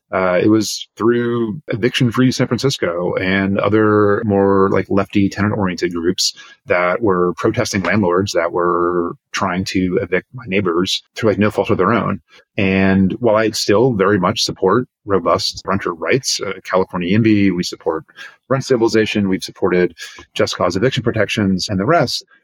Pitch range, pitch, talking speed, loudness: 95-110 Hz, 100 Hz, 155 wpm, -16 LUFS